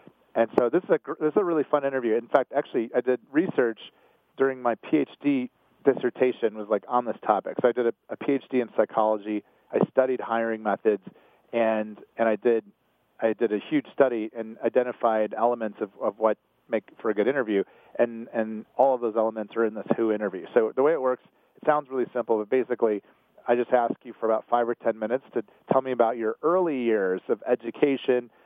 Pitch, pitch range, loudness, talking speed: 120 Hz, 110-130 Hz, -26 LUFS, 210 wpm